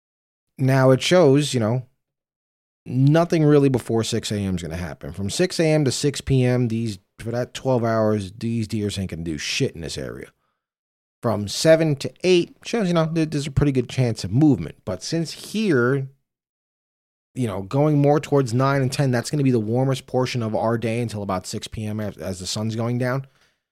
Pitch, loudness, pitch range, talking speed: 125 Hz, -21 LUFS, 110-145 Hz, 200 wpm